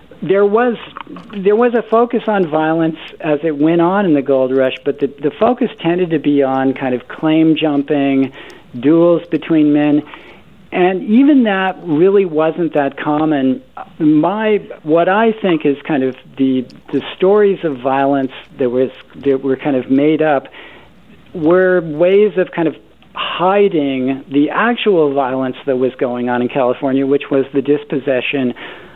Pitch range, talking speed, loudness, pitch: 135-185 Hz, 160 wpm, -14 LUFS, 155 Hz